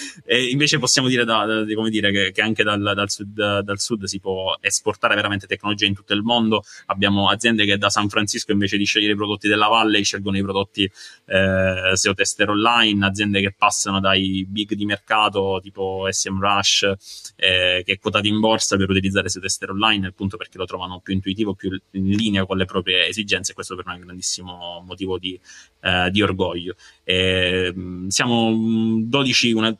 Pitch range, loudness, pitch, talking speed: 95-110 Hz, -19 LUFS, 100 Hz, 190 wpm